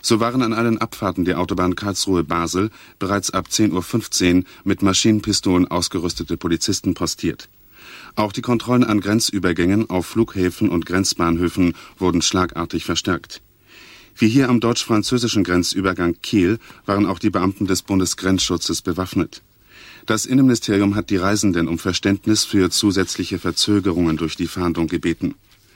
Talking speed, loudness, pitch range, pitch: 135 wpm, -19 LUFS, 90-105 Hz, 95 Hz